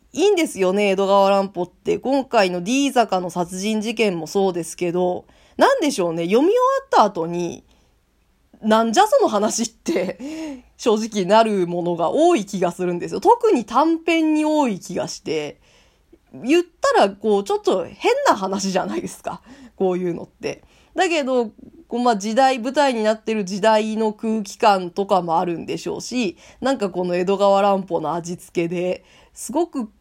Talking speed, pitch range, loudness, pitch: 320 characters per minute, 185-270 Hz, -20 LUFS, 215 Hz